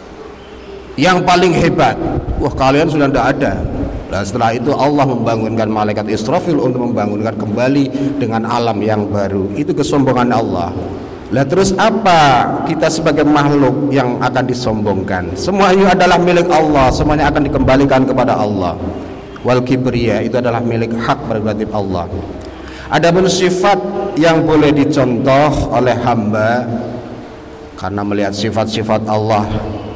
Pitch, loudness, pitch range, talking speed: 125 Hz, -13 LUFS, 110-145 Hz, 125 wpm